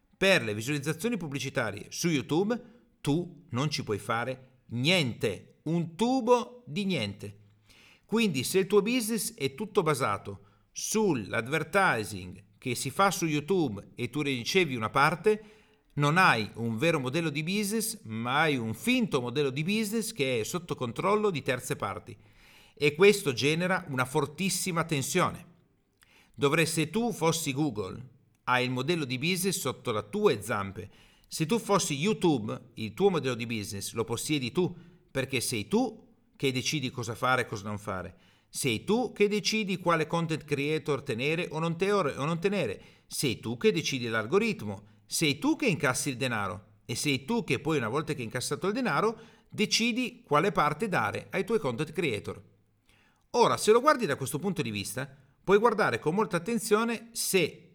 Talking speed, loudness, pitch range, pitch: 165 wpm, -29 LUFS, 125-195 Hz, 150 Hz